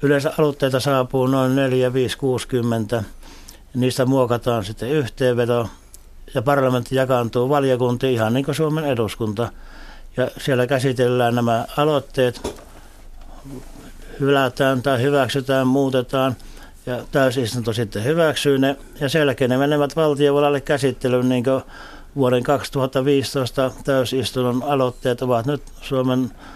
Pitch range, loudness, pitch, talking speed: 125-140 Hz, -20 LUFS, 130 Hz, 110 wpm